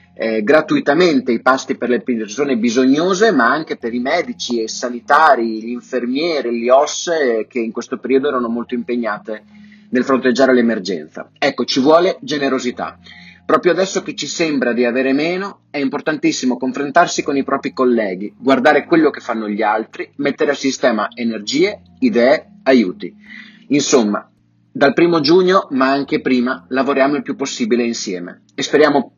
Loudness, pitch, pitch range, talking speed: -16 LUFS, 130 Hz, 120-150 Hz, 155 wpm